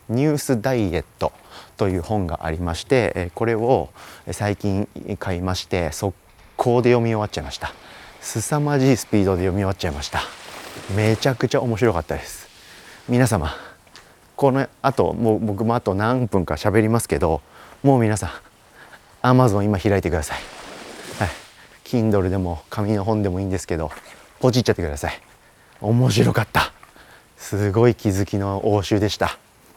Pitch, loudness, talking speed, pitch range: 105 Hz, -21 LUFS, 330 characters per minute, 90-115 Hz